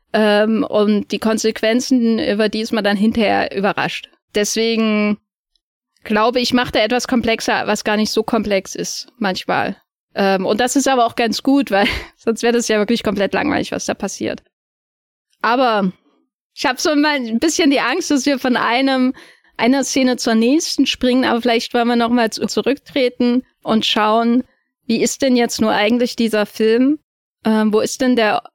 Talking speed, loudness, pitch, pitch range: 170 wpm, -17 LUFS, 230 Hz, 215-255 Hz